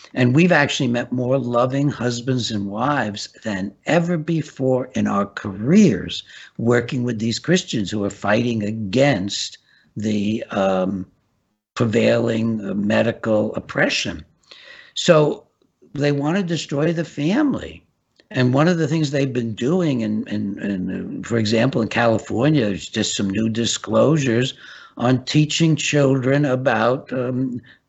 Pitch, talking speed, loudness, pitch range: 120 Hz, 130 wpm, -20 LUFS, 110-145 Hz